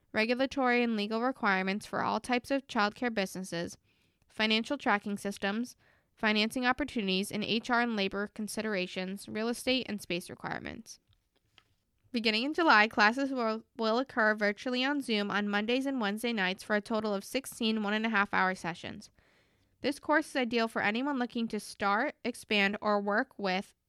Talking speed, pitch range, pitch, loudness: 160 wpm, 200-245 Hz, 215 Hz, -31 LUFS